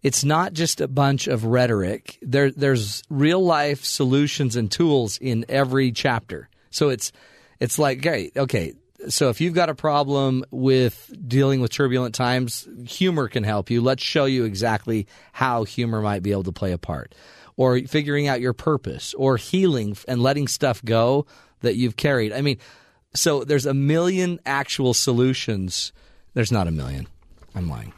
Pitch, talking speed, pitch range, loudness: 130 Hz, 170 wpm, 115-140 Hz, -22 LUFS